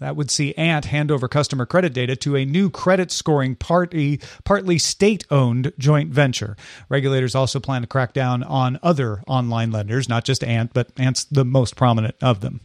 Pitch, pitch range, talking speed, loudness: 135 Hz, 125-150 Hz, 190 wpm, -20 LUFS